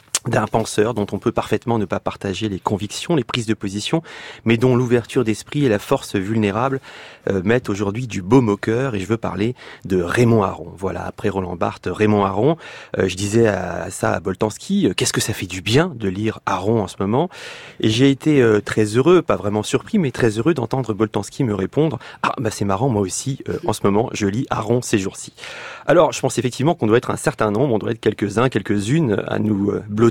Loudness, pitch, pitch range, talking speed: -19 LUFS, 110 Hz, 100-130 Hz, 225 wpm